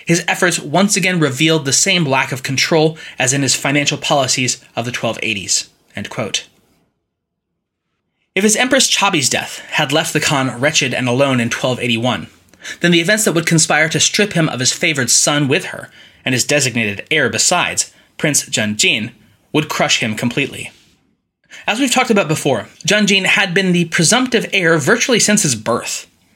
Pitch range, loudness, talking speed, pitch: 130-190 Hz, -14 LUFS, 170 wpm, 155 Hz